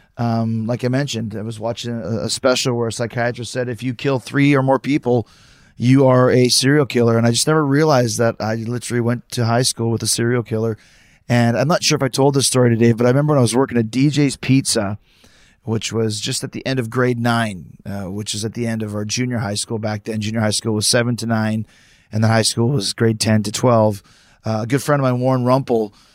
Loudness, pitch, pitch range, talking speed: -18 LUFS, 120 Hz, 110-130 Hz, 250 wpm